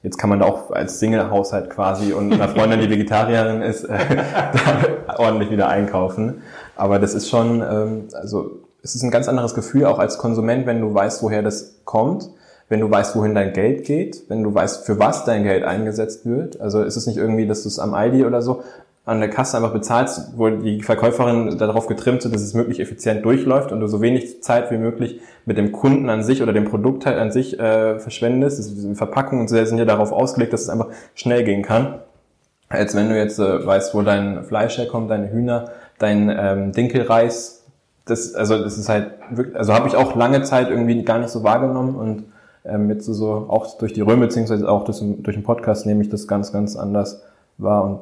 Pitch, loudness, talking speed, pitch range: 110 Hz, -19 LUFS, 220 wpm, 105-120 Hz